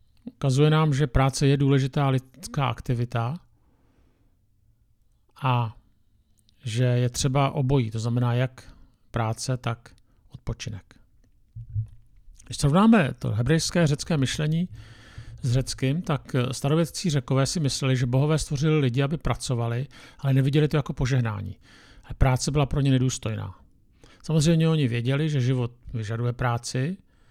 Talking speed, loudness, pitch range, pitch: 120 wpm, -25 LUFS, 115-145 Hz, 130 Hz